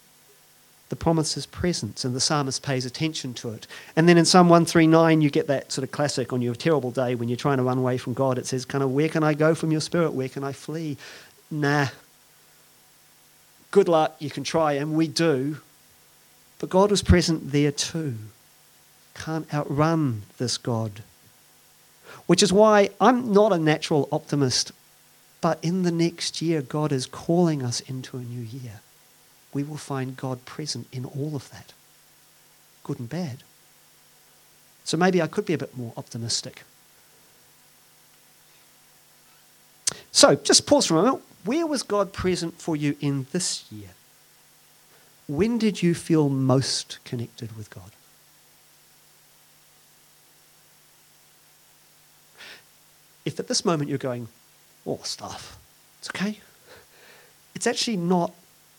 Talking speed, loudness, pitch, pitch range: 150 wpm, -23 LUFS, 145 Hz, 125-165 Hz